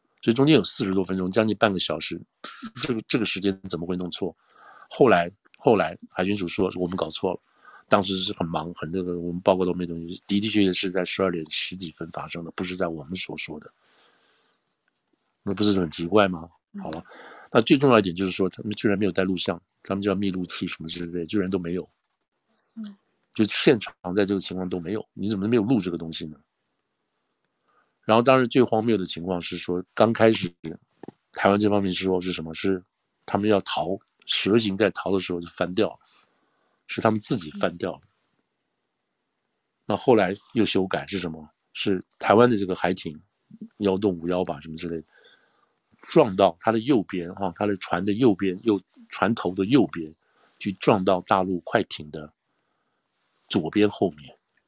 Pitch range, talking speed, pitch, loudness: 85-105 Hz, 275 characters per minute, 95 Hz, -24 LUFS